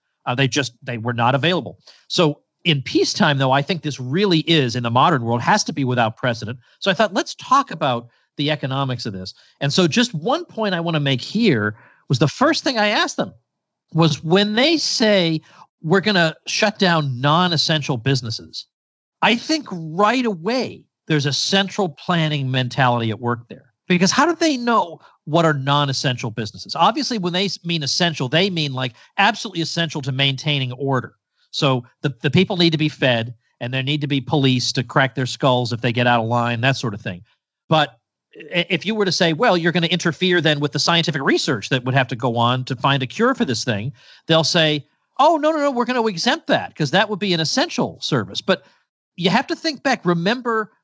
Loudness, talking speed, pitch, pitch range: -19 LUFS, 210 wpm, 155 Hz, 130-195 Hz